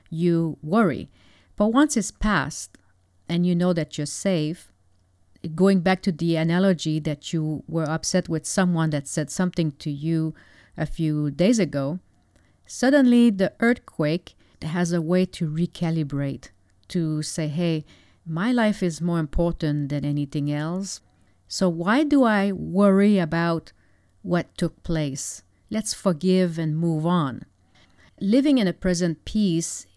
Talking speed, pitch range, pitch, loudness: 140 wpm, 145-185 Hz, 165 Hz, -23 LUFS